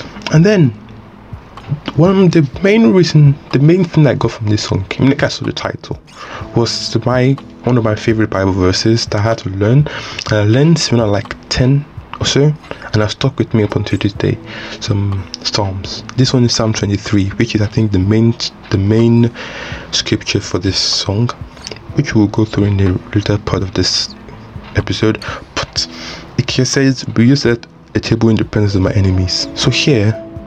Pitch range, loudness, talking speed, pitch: 105-130 Hz, -14 LUFS, 205 wpm, 110 Hz